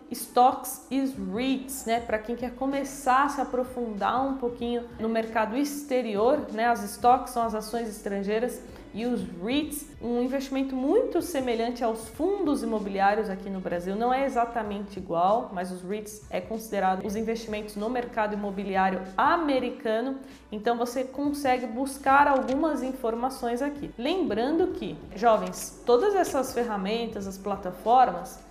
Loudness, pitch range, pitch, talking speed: -27 LUFS, 215-265 Hz, 240 Hz, 140 wpm